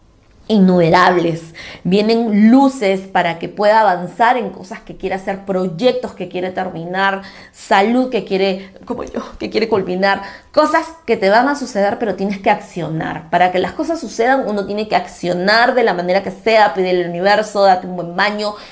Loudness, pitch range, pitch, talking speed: -15 LUFS, 180-220 Hz, 195 Hz, 175 wpm